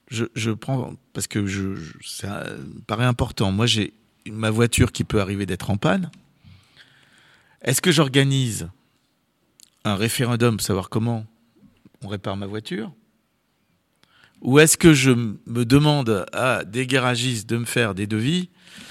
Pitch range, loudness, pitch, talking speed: 105-135 Hz, -21 LUFS, 120 Hz, 150 wpm